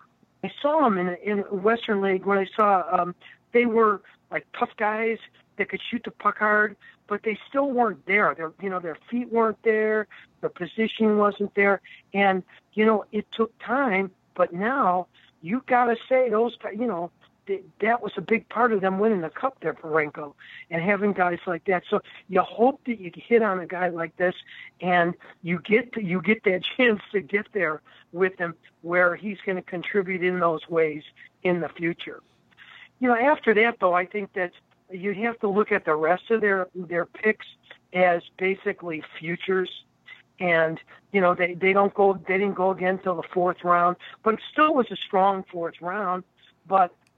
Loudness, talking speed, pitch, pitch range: -24 LUFS, 195 wpm, 195 Hz, 180-220 Hz